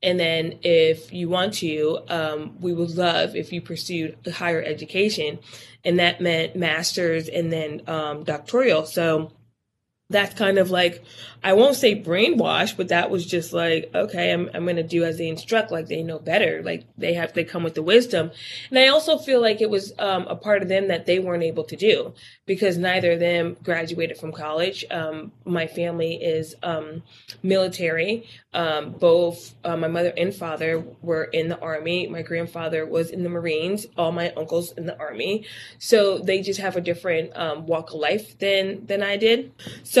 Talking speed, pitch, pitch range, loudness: 190 wpm, 170 Hz, 160-185 Hz, -23 LUFS